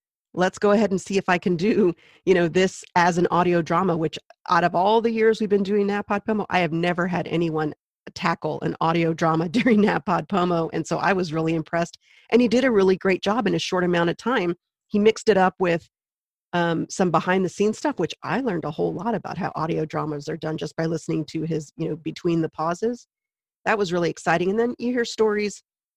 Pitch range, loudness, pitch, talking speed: 165-205 Hz, -23 LUFS, 180 Hz, 225 wpm